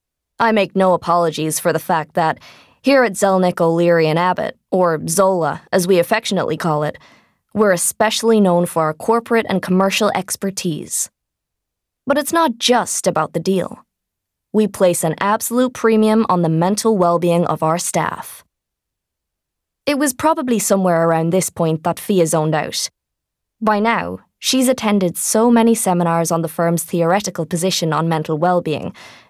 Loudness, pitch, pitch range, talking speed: -17 LUFS, 185 Hz, 170-220 Hz, 155 wpm